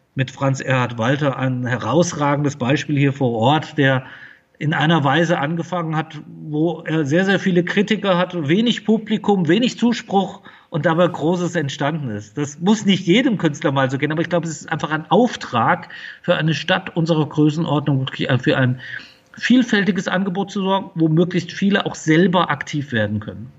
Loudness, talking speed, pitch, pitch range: -19 LUFS, 175 wpm, 165 Hz, 145-185 Hz